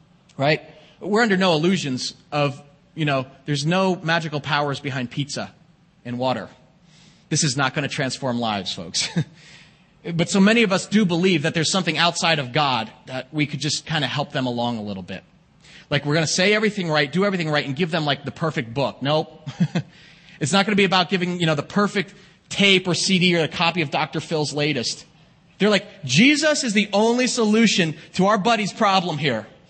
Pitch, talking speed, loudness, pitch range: 165 Hz, 200 wpm, -21 LUFS, 145-185 Hz